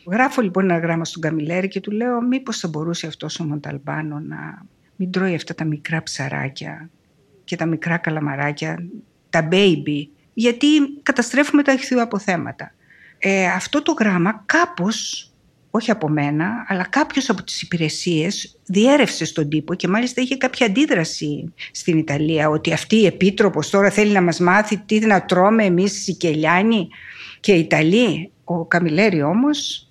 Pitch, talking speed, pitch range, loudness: 185 Hz, 155 wpm, 160-220 Hz, -19 LUFS